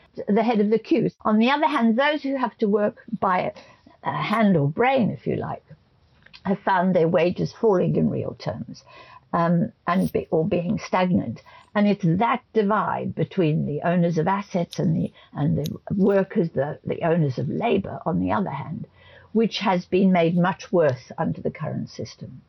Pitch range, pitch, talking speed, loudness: 175-225 Hz, 195 Hz, 180 wpm, -23 LUFS